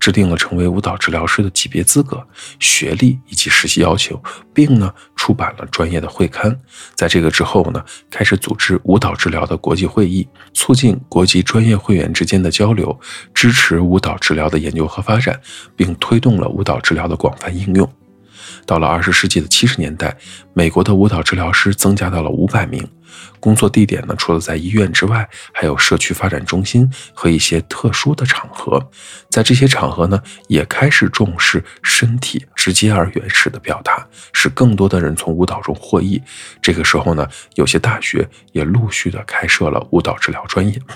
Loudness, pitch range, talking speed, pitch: -14 LUFS, 85-110 Hz, 290 characters per minute, 95 Hz